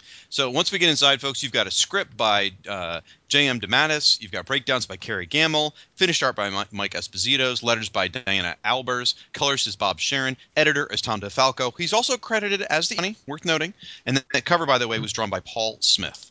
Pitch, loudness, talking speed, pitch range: 135 Hz, -22 LUFS, 205 wpm, 110-155 Hz